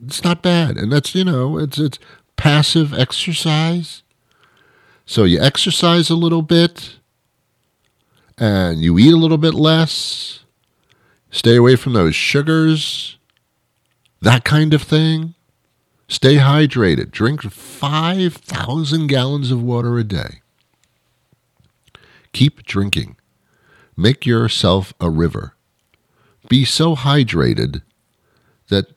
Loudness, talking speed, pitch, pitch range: -15 LUFS, 110 wpm, 140 Hz, 115-160 Hz